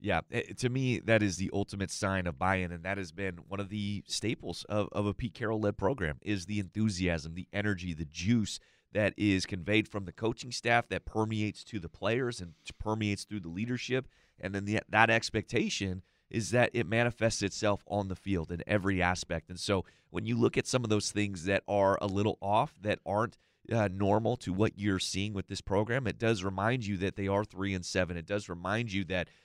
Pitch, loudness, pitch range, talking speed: 100 Hz, -32 LUFS, 95-110 Hz, 215 wpm